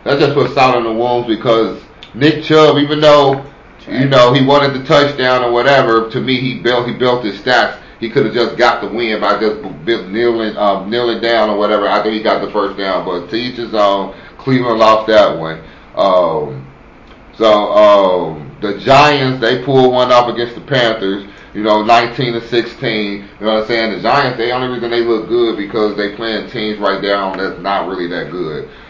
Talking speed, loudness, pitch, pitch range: 210 wpm, -13 LUFS, 115 Hz, 105-130 Hz